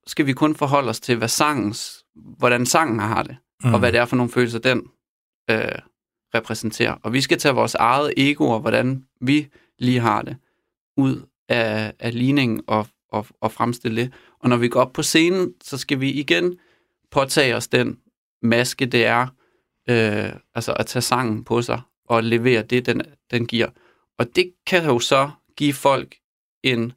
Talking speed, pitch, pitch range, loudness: 180 wpm, 125 Hz, 115-140 Hz, -20 LUFS